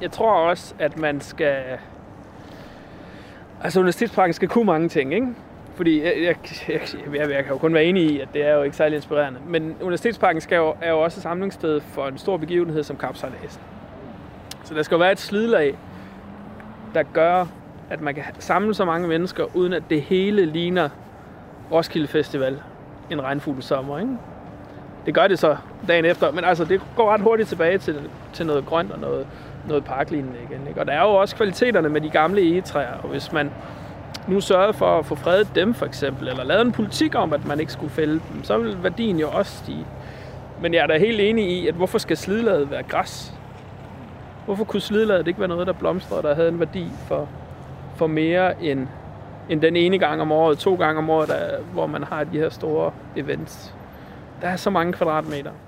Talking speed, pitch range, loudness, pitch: 200 wpm, 145-185 Hz, -21 LUFS, 160 Hz